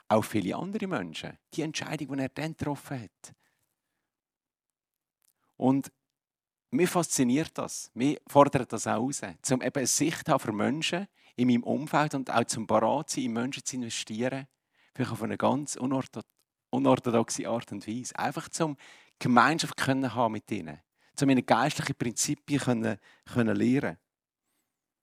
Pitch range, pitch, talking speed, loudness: 115-140 Hz, 130 Hz, 145 wpm, -29 LUFS